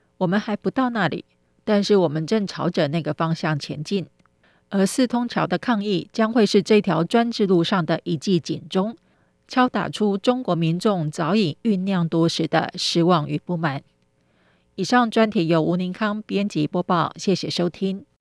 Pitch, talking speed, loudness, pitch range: 185 Hz, 250 characters per minute, -22 LUFS, 165-210 Hz